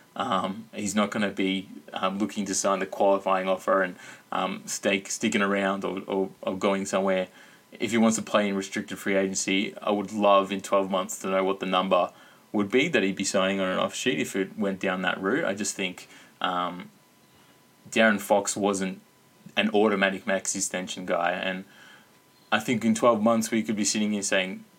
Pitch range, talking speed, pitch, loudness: 95-105 Hz, 200 wpm, 100 Hz, -26 LUFS